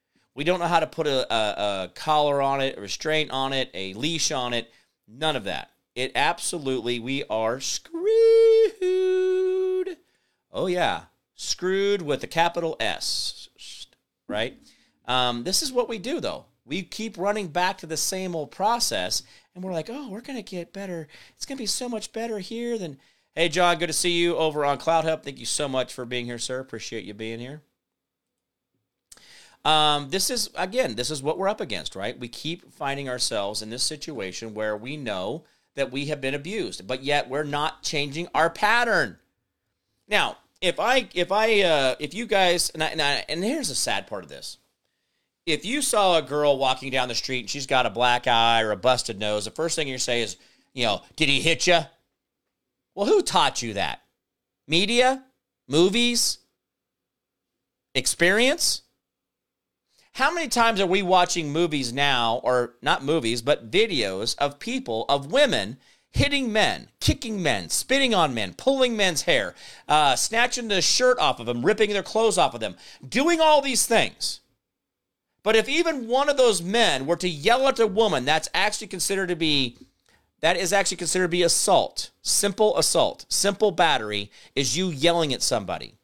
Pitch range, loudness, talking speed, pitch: 135-220 Hz, -23 LUFS, 180 wpm, 165 Hz